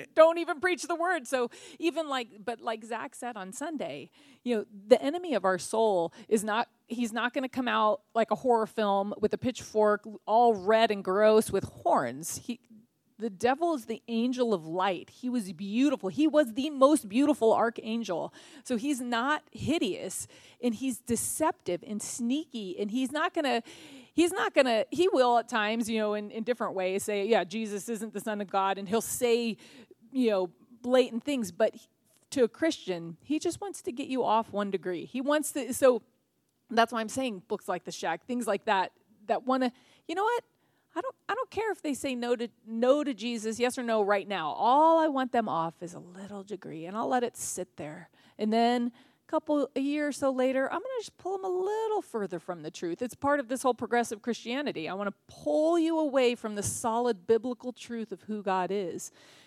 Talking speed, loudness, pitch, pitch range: 220 wpm, -29 LUFS, 235 Hz, 210-280 Hz